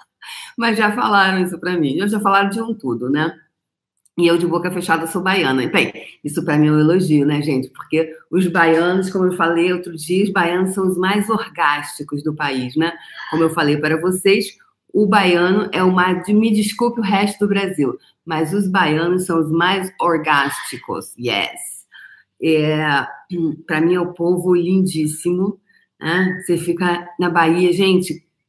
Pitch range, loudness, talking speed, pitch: 160-190 Hz, -17 LUFS, 175 wpm, 175 Hz